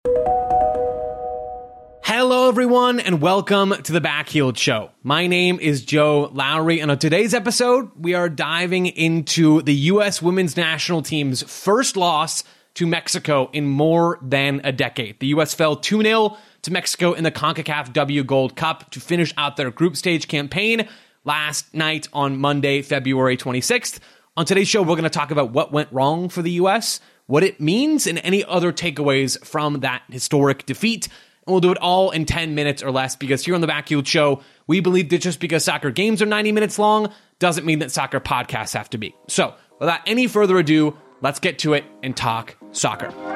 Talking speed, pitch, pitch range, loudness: 180 wpm, 160 Hz, 140-180 Hz, -19 LUFS